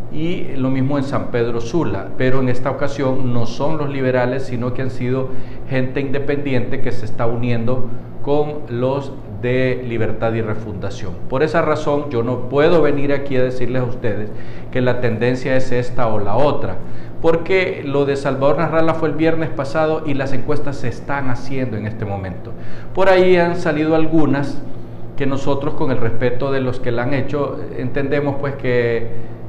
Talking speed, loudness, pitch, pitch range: 180 wpm, -19 LUFS, 130 Hz, 120-145 Hz